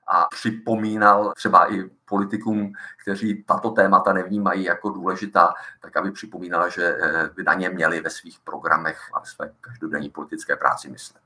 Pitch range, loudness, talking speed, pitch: 90-110 Hz, -22 LUFS, 145 wpm, 105 Hz